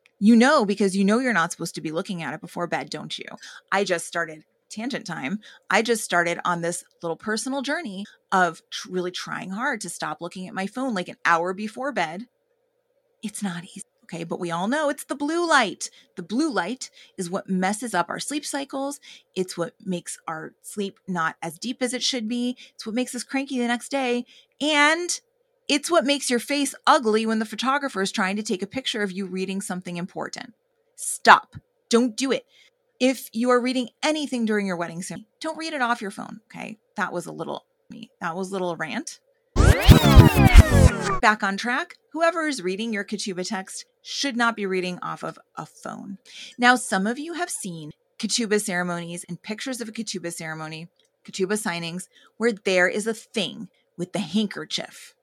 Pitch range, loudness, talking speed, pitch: 185-265 Hz, -24 LUFS, 195 wpm, 220 Hz